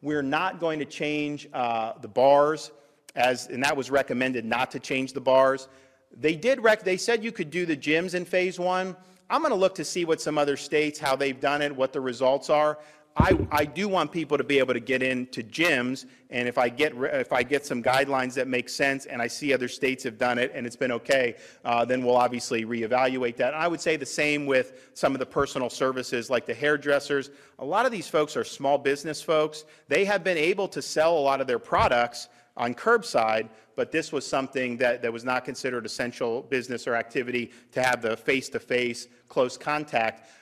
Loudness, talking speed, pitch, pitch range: -26 LUFS, 225 wpm, 135 Hz, 125-150 Hz